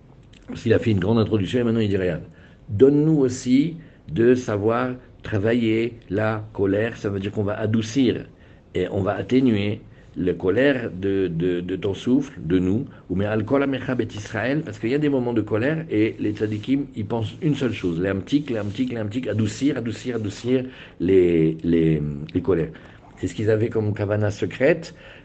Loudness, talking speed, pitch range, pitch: -22 LUFS, 185 wpm, 100-125 Hz, 110 Hz